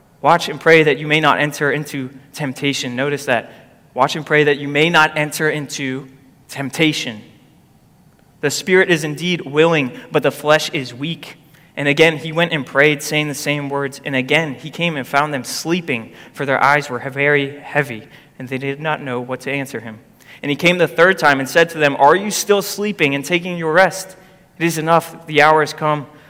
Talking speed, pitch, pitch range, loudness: 205 wpm, 150 Hz, 140-160 Hz, -16 LUFS